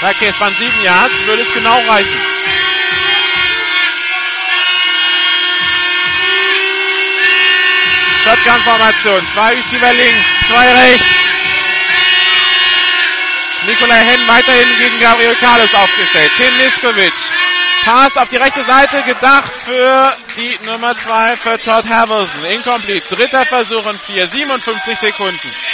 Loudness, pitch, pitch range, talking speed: -9 LUFS, 240 Hz, 220-270 Hz, 105 wpm